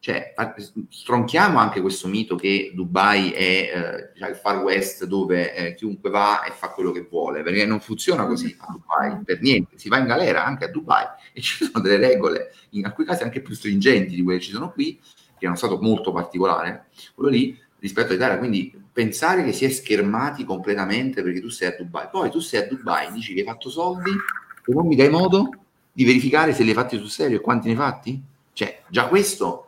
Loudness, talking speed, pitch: -21 LUFS, 220 wpm, 115 Hz